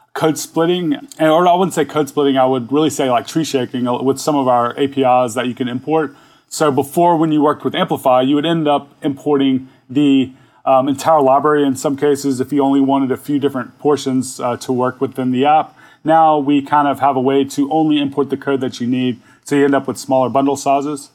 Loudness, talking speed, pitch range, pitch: -16 LUFS, 230 wpm, 130-150 Hz, 140 Hz